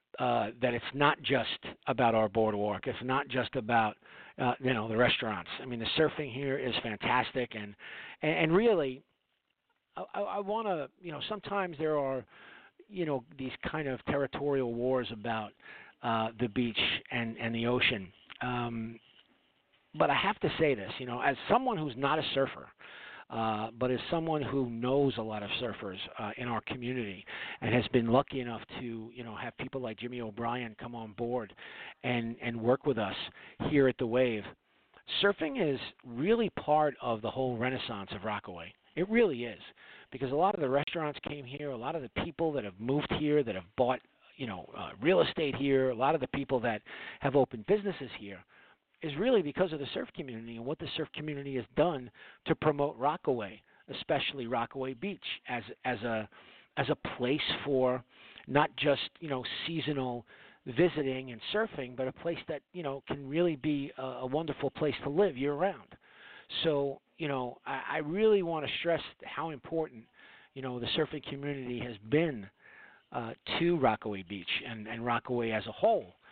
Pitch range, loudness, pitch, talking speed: 115-150 Hz, -33 LUFS, 130 Hz, 185 wpm